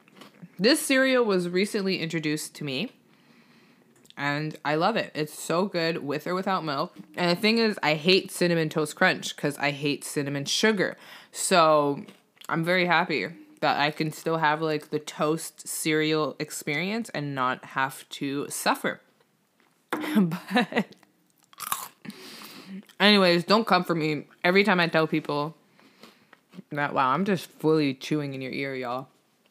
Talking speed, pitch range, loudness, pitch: 145 wpm, 150-195 Hz, -25 LUFS, 165 Hz